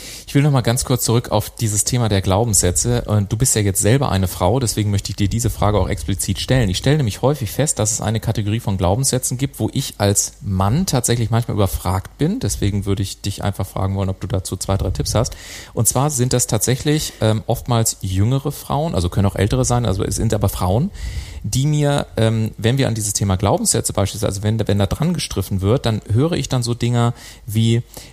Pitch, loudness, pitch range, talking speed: 110 Hz, -18 LUFS, 100-125 Hz, 220 wpm